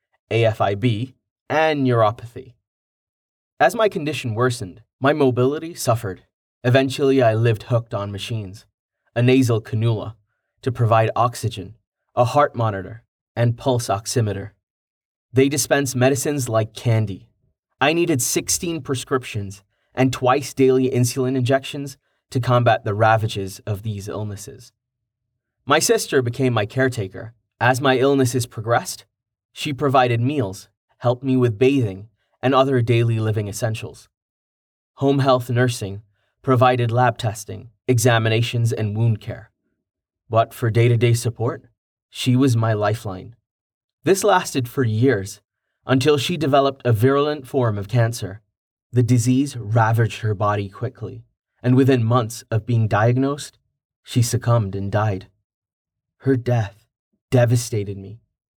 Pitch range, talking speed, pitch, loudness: 110-130 Hz, 125 wpm, 120 Hz, -20 LUFS